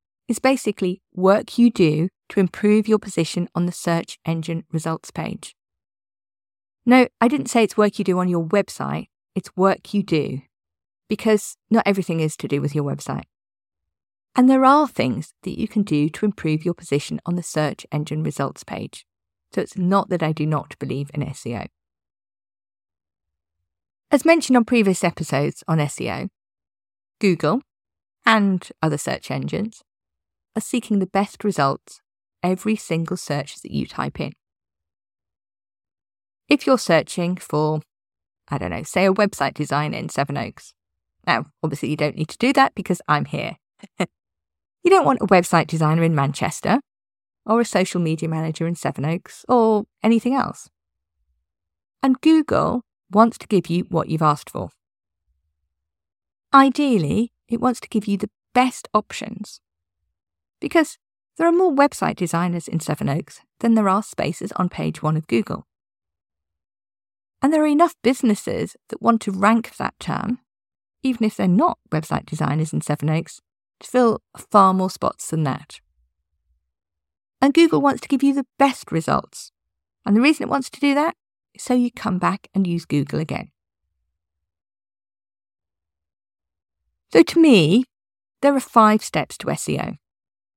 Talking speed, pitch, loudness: 155 wpm, 170 Hz, -20 LUFS